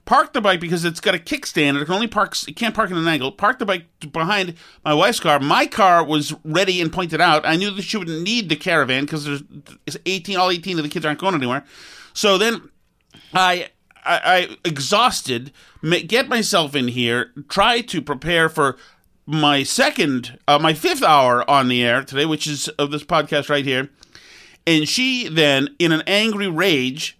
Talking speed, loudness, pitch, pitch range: 200 wpm, -18 LUFS, 160 Hz, 145-190 Hz